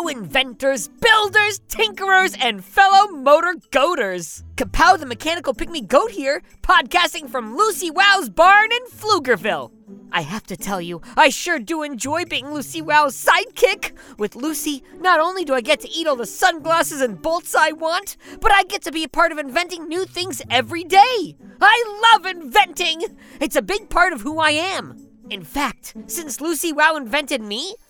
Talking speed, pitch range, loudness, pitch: 170 wpm, 275-375 Hz, -18 LUFS, 320 Hz